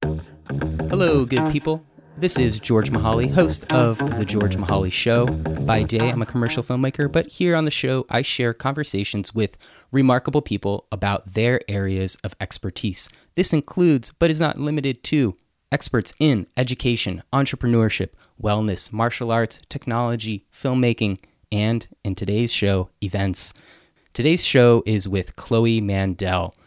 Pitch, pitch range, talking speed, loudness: 115 Hz, 100-130 Hz, 140 wpm, -21 LUFS